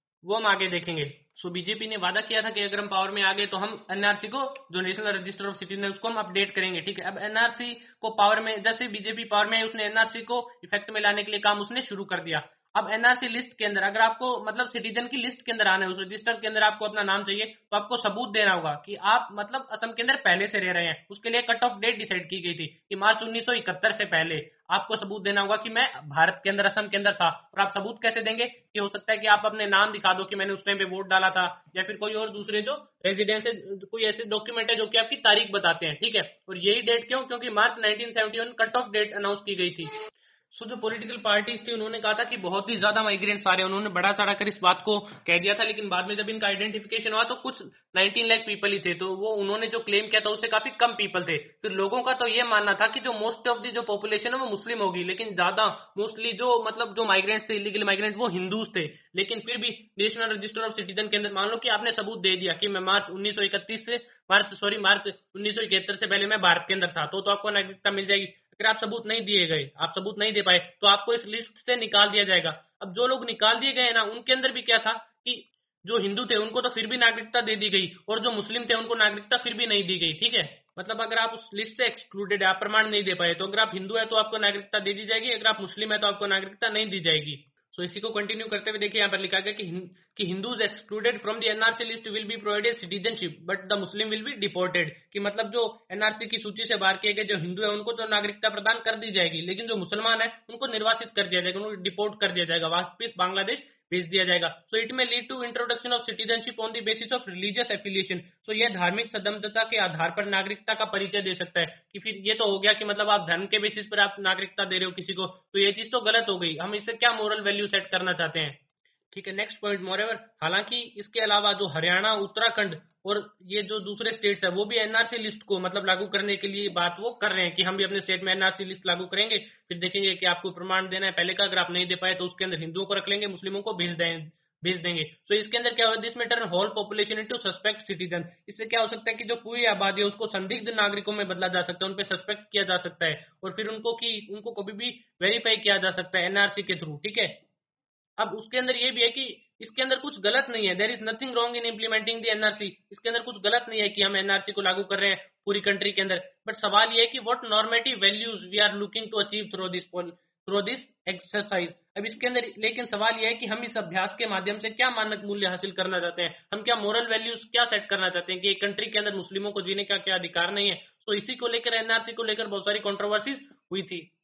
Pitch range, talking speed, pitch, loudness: 190-225 Hz, 260 wpm, 210 Hz, -25 LUFS